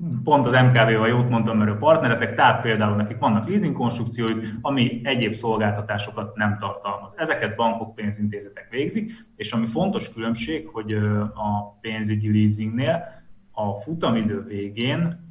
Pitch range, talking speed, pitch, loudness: 105-125 Hz, 135 wpm, 115 Hz, -22 LUFS